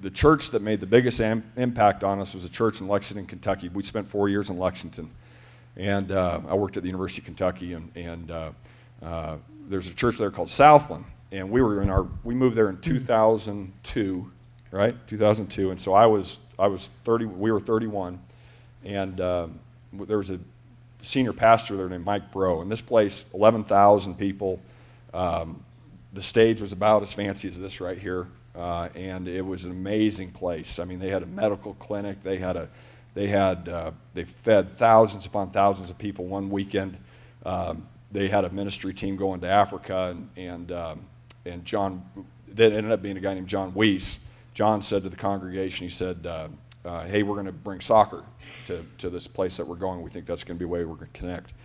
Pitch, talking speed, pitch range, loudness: 100 Hz, 205 wpm, 90-110 Hz, -25 LUFS